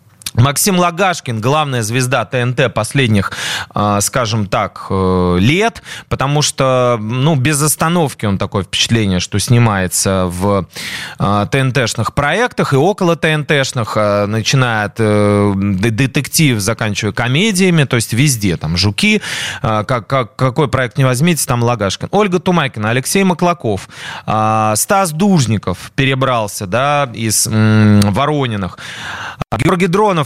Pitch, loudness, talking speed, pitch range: 125 Hz, -14 LUFS, 110 wpm, 105-150 Hz